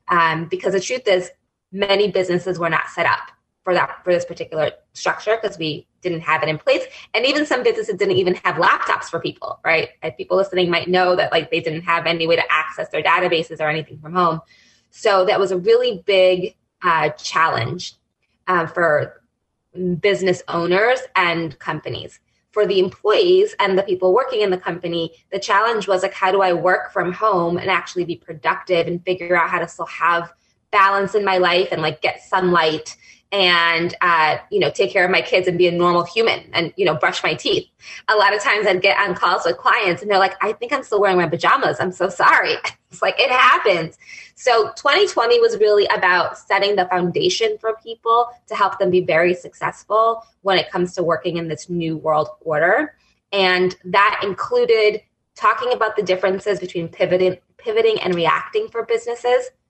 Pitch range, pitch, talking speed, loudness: 170-215 Hz, 185 Hz, 195 wpm, -18 LUFS